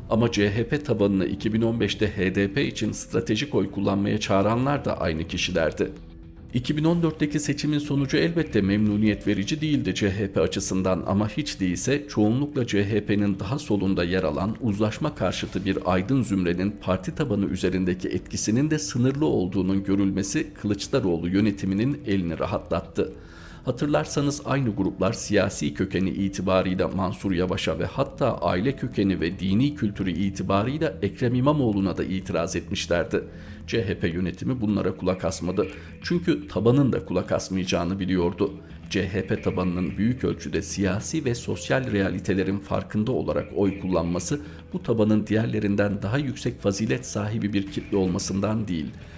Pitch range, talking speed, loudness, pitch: 95-115 Hz, 125 wpm, -25 LUFS, 100 Hz